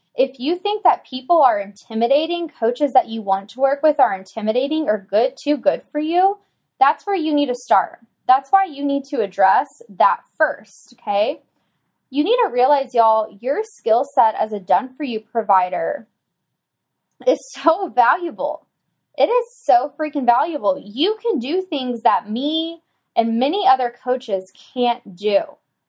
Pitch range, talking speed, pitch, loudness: 230-325 Hz, 160 wpm, 275 Hz, -19 LUFS